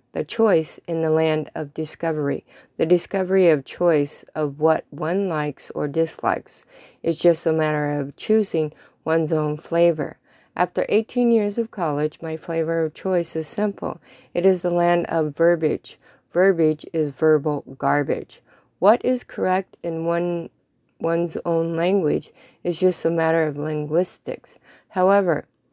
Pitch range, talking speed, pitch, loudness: 155-180 Hz, 140 wpm, 165 Hz, -22 LUFS